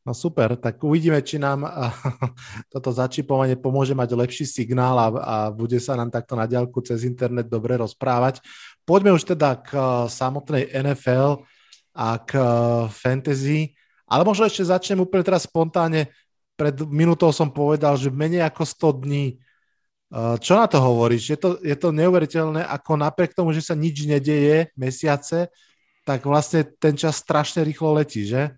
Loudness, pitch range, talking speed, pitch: -21 LUFS, 125-160 Hz, 155 wpm, 145 Hz